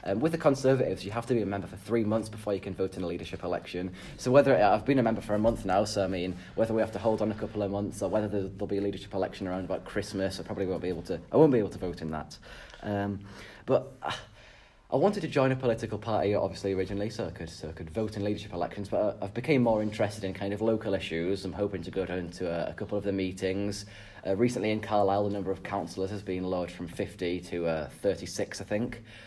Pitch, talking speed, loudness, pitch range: 100 Hz, 265 wpm, -30 LUFS, 95-110 Hz